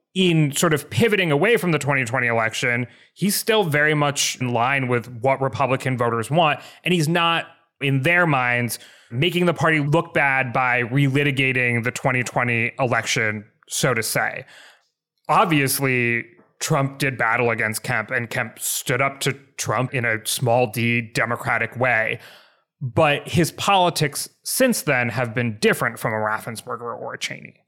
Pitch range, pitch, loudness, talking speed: 120-155 Hz, 135 Hz, -20 LUFS, 155 wpm